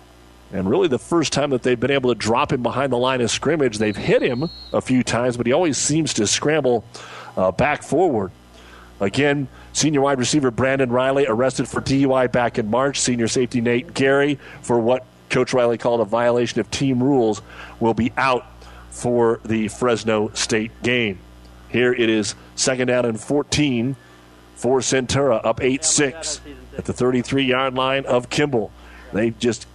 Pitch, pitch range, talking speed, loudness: 120 Hz, 110-135 Hz, 175 wpm, -20 LUFS